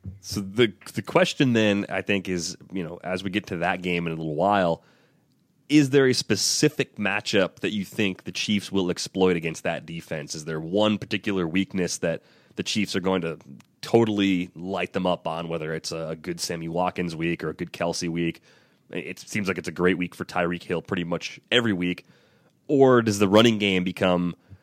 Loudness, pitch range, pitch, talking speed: -25 LUFS, 85-105 Hz, 95 Hz, 200 wpm